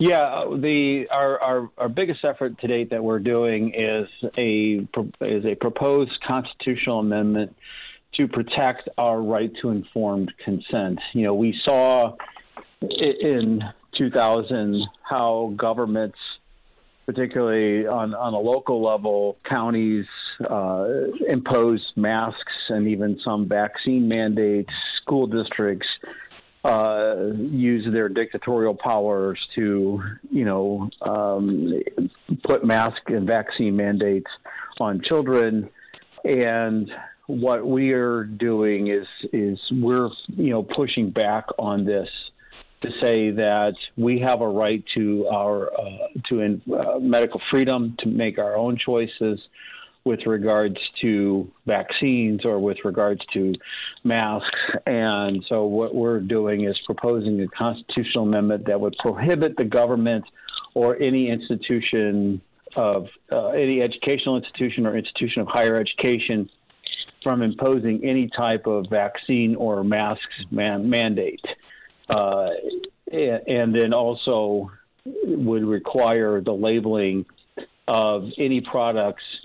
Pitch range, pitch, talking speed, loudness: 105-120 Hz, 110 Hz, 120 wpm, -23 LUFS